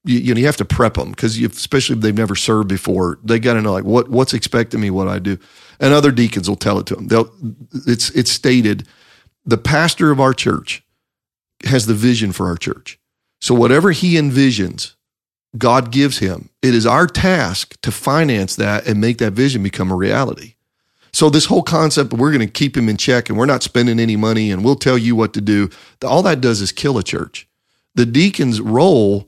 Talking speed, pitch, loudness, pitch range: 215 wpm, 120 Hz, -15 LUFS, 105-135 Hz